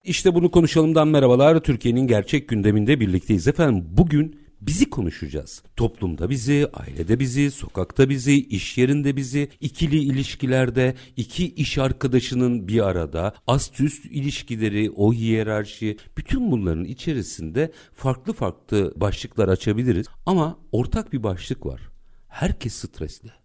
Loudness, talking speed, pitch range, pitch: -22 LUFS, 120 wpm, 105-145 Hz, 125 Hz